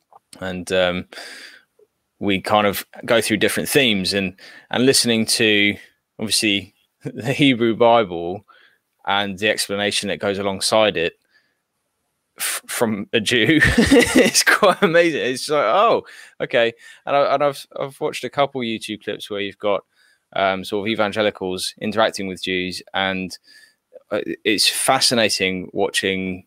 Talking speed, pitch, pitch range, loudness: 135 wpm, 105 Hz, 95-135 Hz, -19 LUFS